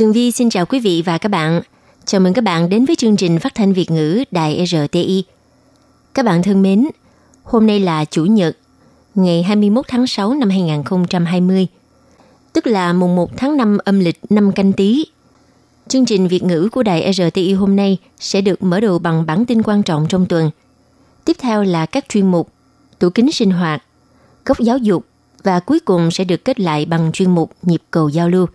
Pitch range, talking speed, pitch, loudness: 170-220 Hz, 200 wpm, 190 Hz, -15 LUFS